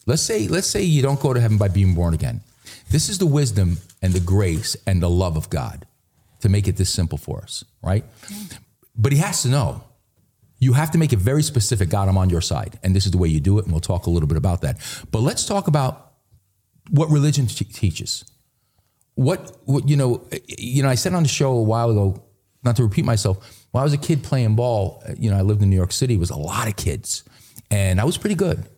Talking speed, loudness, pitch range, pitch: 245 wpm, -20 LUFS, 95-135 Hz, 115 Hz